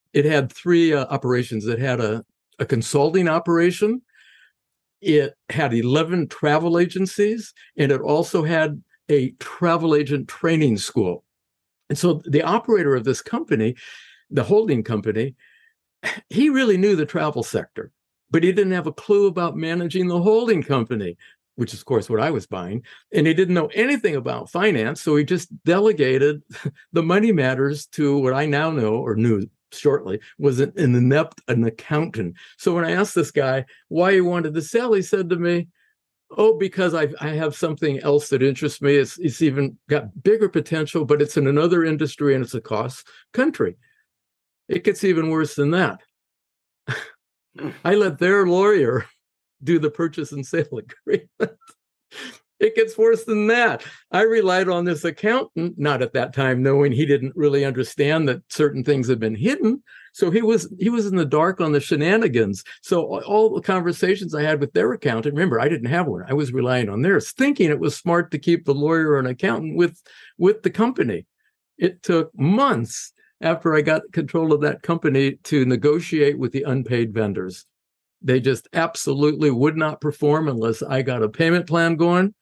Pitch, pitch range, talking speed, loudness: 155 Hz, 140-180 Hz, 180 wpm, -20 LUFS